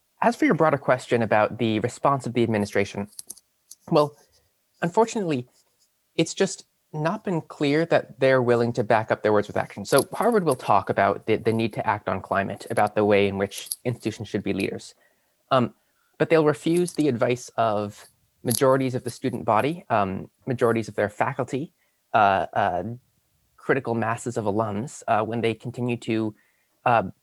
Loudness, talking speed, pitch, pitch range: -24 LUFS, 170 wpm, 120 Hz, 110-145 Hz